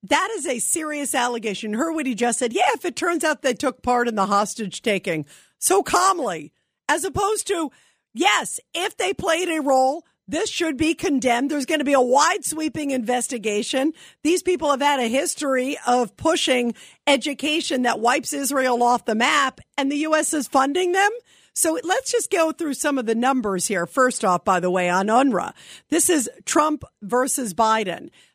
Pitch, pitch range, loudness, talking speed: 275 Hz, 240-320 Hz, -21 LUFS, 185 wpm